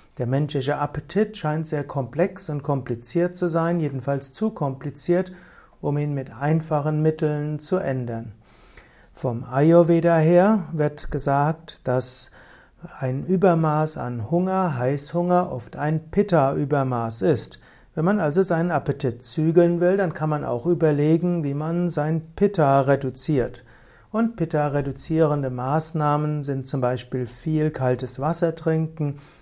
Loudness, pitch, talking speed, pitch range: -23 LUFS, 150 Hz, 125 wpm, 135-165 Hz